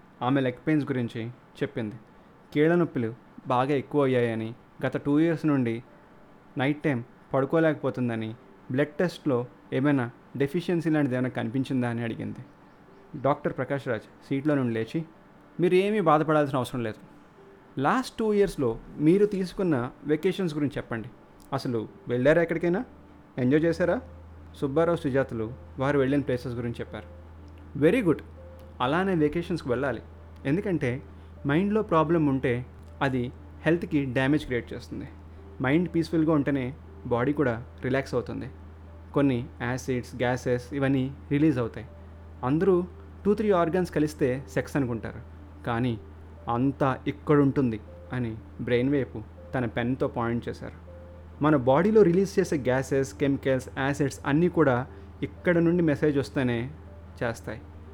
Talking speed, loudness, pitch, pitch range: 120 wpm, -27 LUFS, 130 Hz, 115-150 Hz